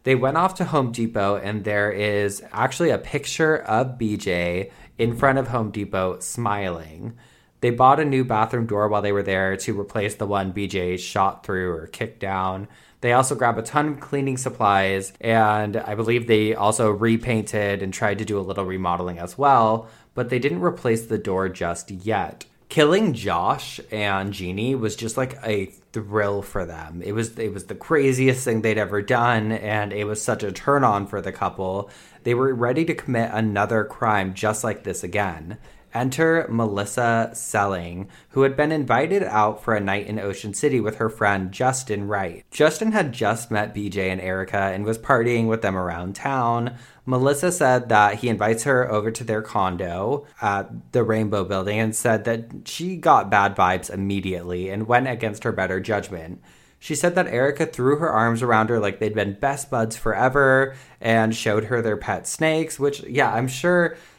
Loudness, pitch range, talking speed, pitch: -22 LUFS, 100-125 Hz, 185 wpm, 110 Hz